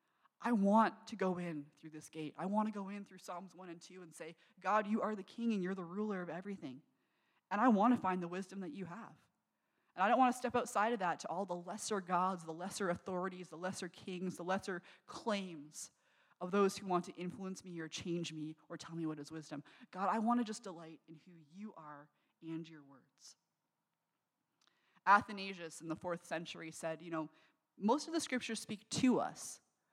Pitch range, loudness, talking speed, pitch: 165-205 Hz, -39 LUFS, 215 wpm, 185 Hz